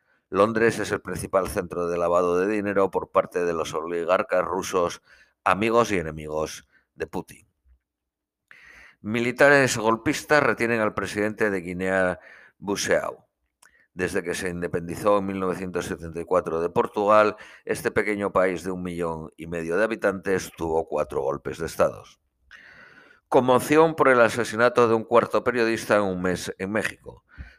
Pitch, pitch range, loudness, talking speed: 95 Hz, 85-115 Hz, -24 LUFS, 140 wpm